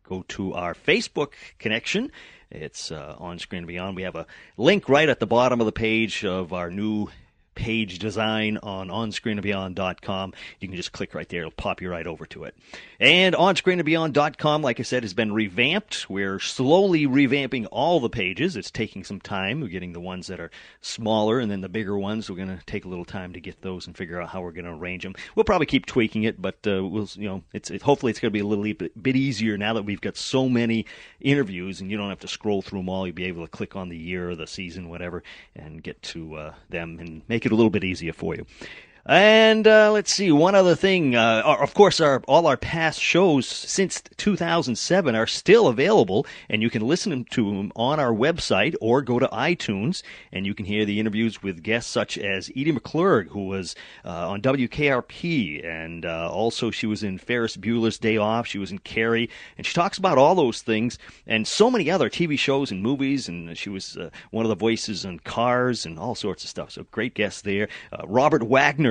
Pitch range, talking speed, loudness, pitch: 95-125 Hz, 220 wpm, -23 LUFS, 110 Hz